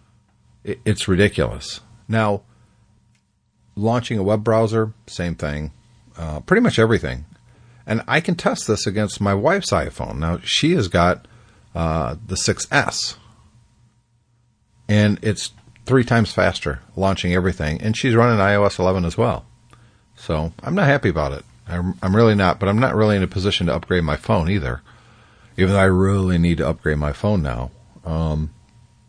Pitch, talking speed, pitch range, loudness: 105 Hz, 160 wpm, 90-115 Hz, -19 LUFS